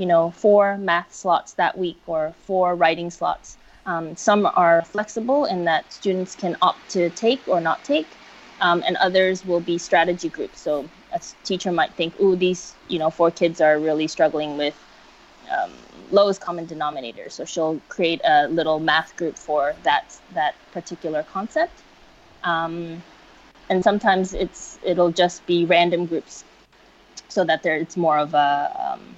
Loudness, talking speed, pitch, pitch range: -21 LUFS, 165 wpm, 175 Hz, 160-190 Hz